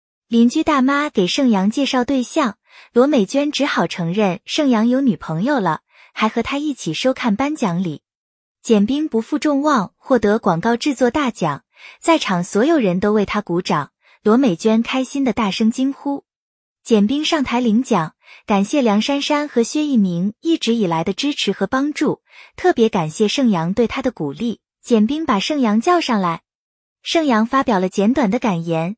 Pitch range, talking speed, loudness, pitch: 205-280 Hz, 255 characters per minute, -18 LUFS, 235 Hz